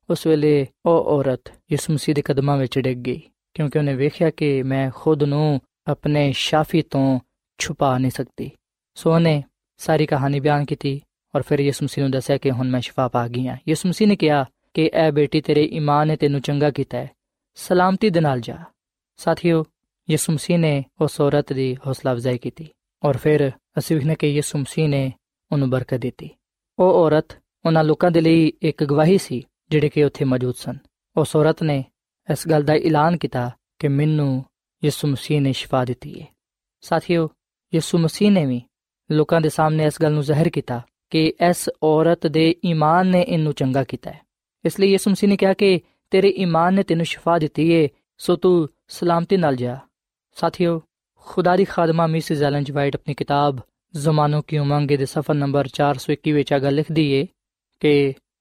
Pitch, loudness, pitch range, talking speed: 150 Hz, -20 LUFS, 140-165 Hz, 175 wpm